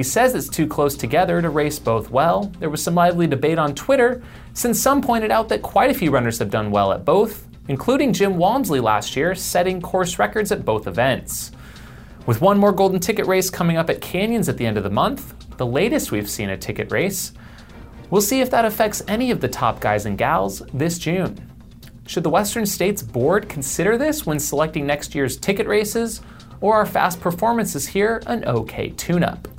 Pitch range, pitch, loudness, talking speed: 140-210 Hz, 180 Hz, -20 LUFS, 205 wpm